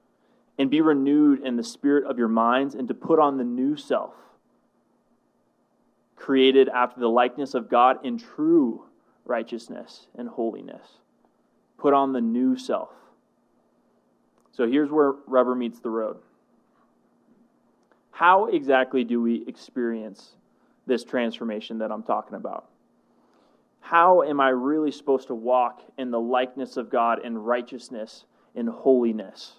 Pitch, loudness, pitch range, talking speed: 125 Hz, -23 LUFS, 115-140 Hz, 135 wpm